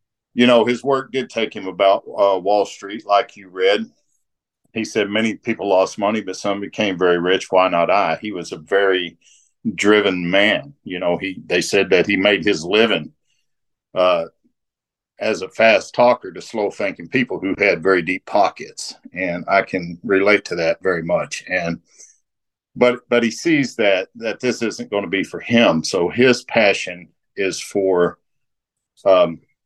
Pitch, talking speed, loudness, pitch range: 100 Hz, 175 wpm, -18 LUFS, 95-120 Hz